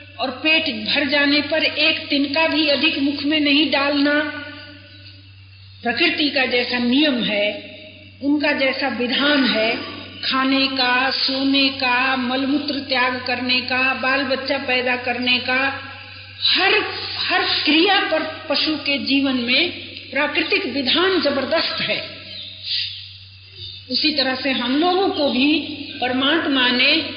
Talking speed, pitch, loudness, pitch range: 125 wpm, 275 Hz, -18 LUFS, 250-295 Hz